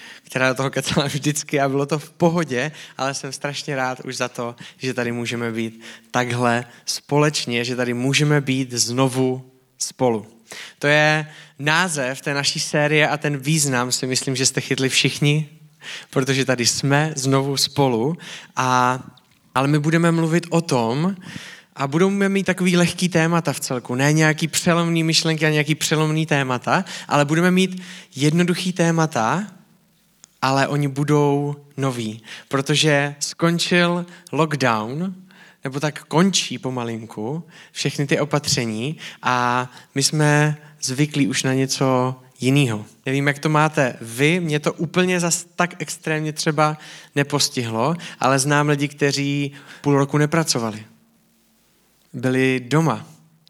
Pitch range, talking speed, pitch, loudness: 130-160 Hz, 135 wpm, 145 Hz, -20 LUFS